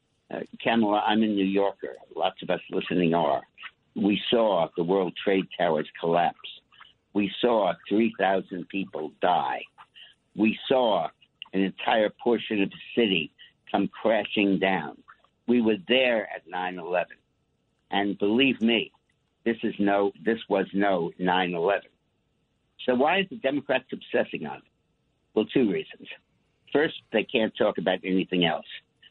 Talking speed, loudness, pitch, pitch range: 140 wpm, -26 LUFS, 100 Hz, 95-110 Hz